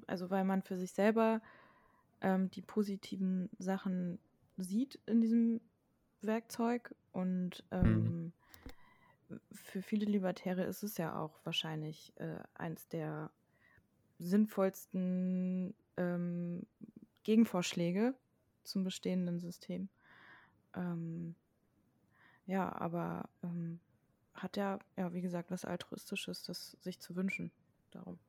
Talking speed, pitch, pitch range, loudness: 105 wpm, 185 Hz, 175-200 Hz, -38 LUFS